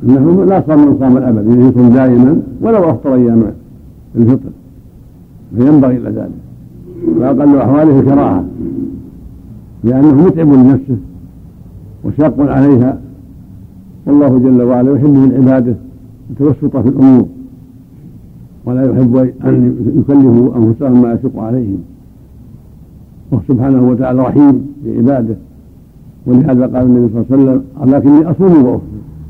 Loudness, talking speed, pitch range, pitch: -9 LUFS, 110 wpm, 110-135 Hz, 125 Hz